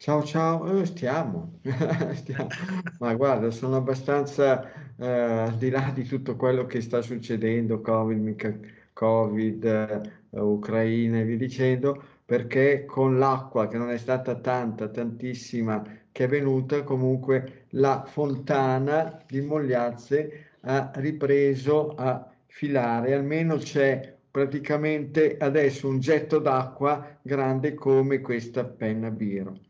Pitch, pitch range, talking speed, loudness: 130 Hz, 120-145 Hz, 120 wpm, -26 LUFS